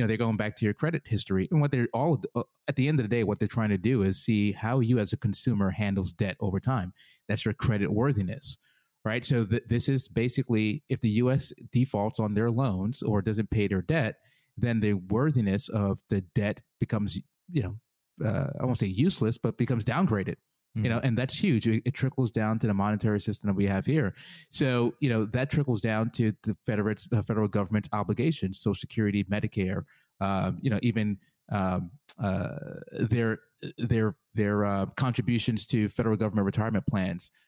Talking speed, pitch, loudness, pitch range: 195 wpm, 110 Hz, -28 LUFS, 105-125 Hz